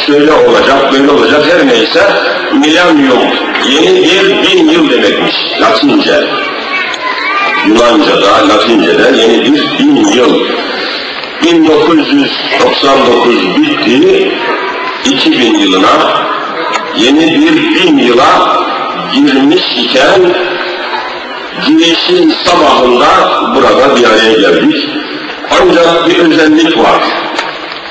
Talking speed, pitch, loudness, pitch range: 85 wpm, 320 Hz, -7 LUFS, 295-360 Hz